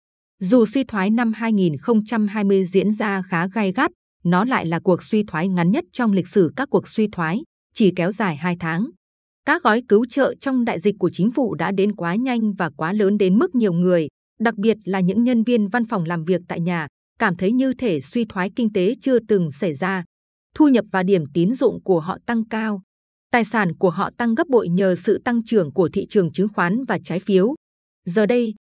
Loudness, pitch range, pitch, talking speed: -20 LUFS, 185-230 Hz, 205 Hz, 220 wpm